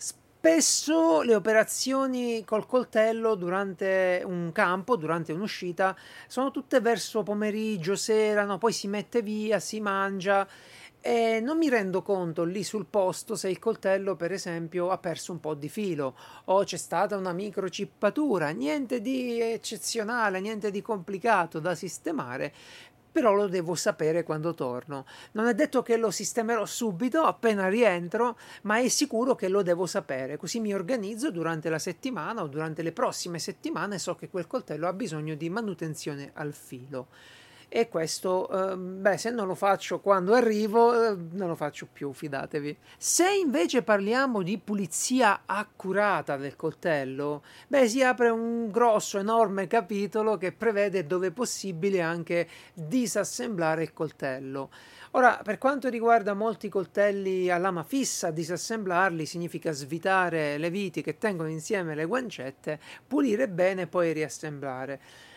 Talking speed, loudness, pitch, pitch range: 145 wpm, -28 LUFS, 195 Hz, 170-225 Hz